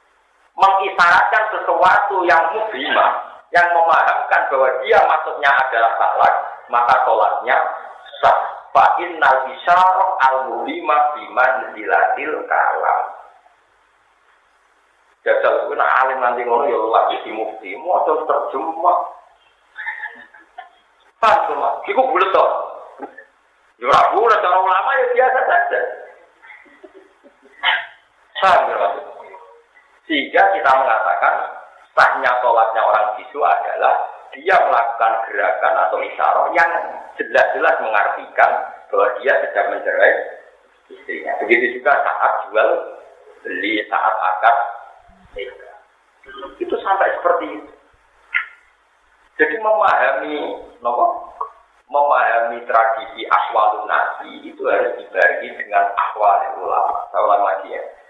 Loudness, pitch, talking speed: -16 LUFS, 340 Hz, 95 wpm